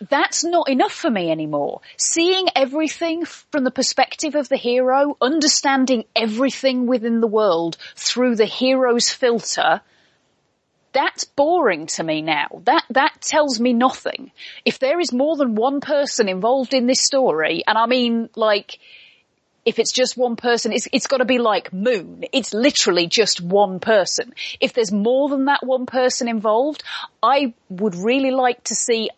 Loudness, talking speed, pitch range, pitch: -19 LUFS, 160 wpm, 225-275 Hz, 255 Hz